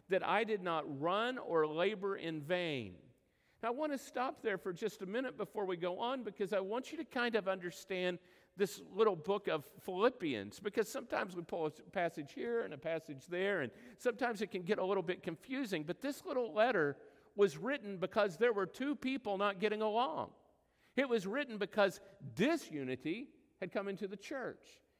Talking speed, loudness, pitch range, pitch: 190 wpm, -38 LUFS, 180-235 Hz, 200 Hz